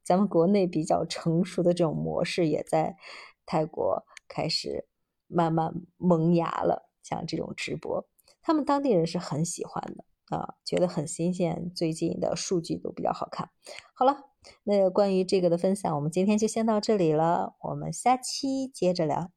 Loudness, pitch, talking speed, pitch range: -28 LUFS, 180 Hz, 255 characters per minute, 165-205 Hz